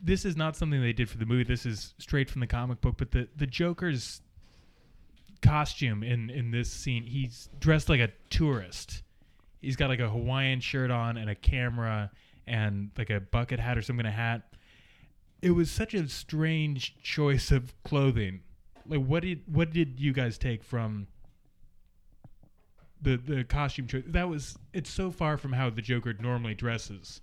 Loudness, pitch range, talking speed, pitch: -30 LUFS, 115-145 Hz, 180 wpm, 125 Hz